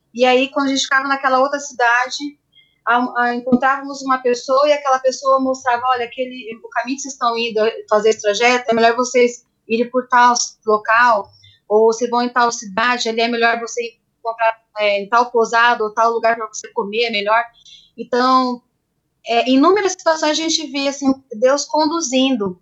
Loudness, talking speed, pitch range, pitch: -16 LUFS, 185 wpm, 230-265 Hz, 245 Hz